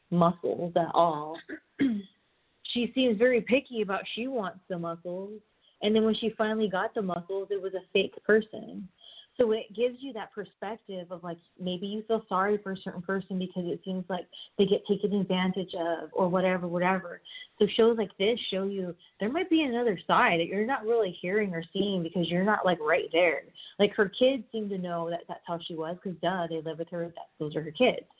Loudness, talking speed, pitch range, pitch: -29 LUFS, 210 wpm, 180-220 Hz, 195 Hz